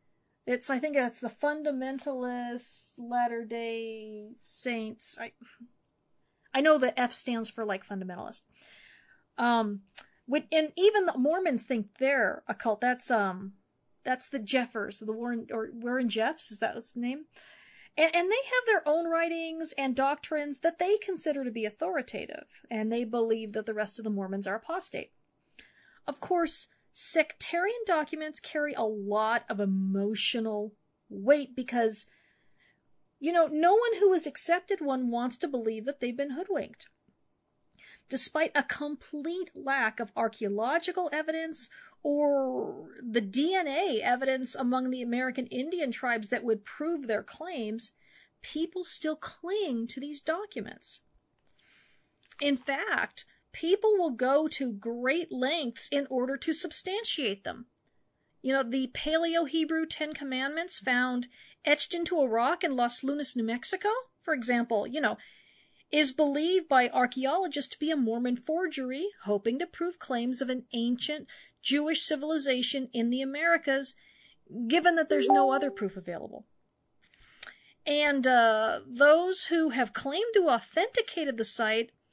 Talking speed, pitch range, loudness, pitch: 140 wpm, 235-320 Hz, -29 LUFS, 270 Hz